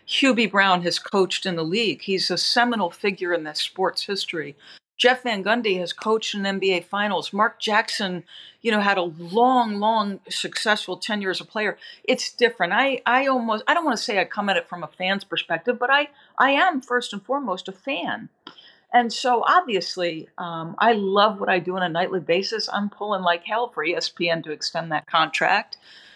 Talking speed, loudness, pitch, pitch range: 195 wpm, -22 LUFS, 200 Hz, 180-235 Hz